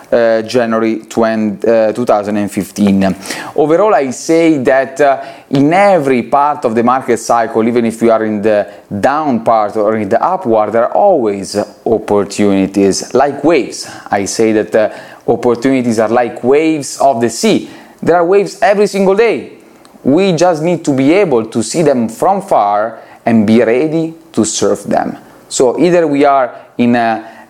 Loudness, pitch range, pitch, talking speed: -12 LUFS, 110-140 Hz, 115 Hz, 165 wpm